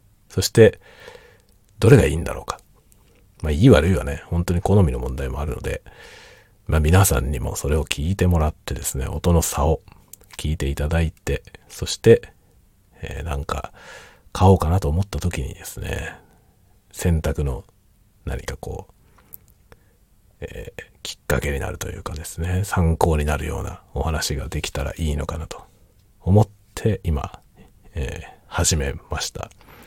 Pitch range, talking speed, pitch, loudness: 75-95 Hz, 285 characters per minute, 85 Hz, -21 LUFS